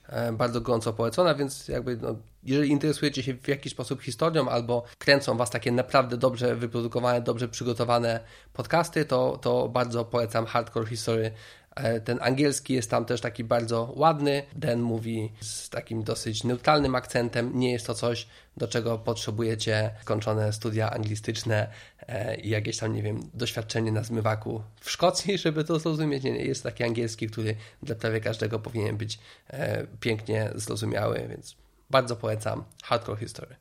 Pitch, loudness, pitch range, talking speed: 120 Hz, -28 LUFS, 110-130 Hz, 150 wpm